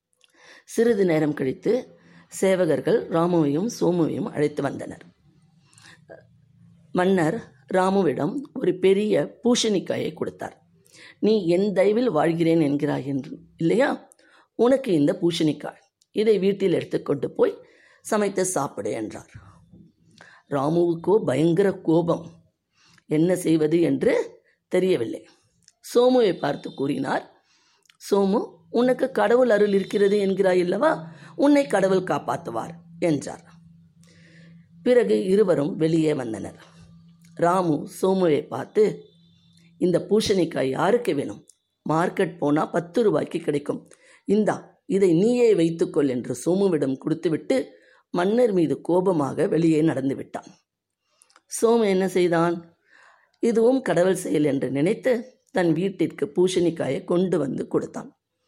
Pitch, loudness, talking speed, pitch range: 175 Hz, -23 LUFS, 95 wpm, 160-205 Hz